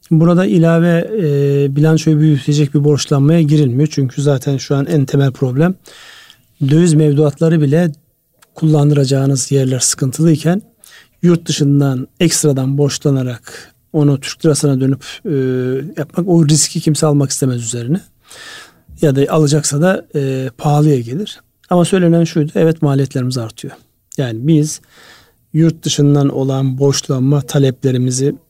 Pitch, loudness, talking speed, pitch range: 150 Hz, -14 LUFS, 120 wpm, 140-165 Hz